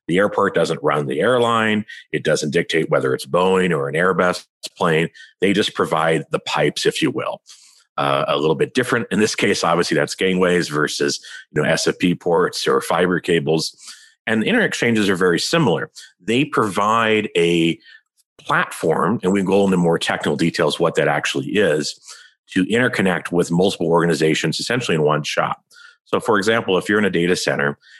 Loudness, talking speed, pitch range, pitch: -18 LUFS, 180 wpm, 80-100 Hz, 90 Hz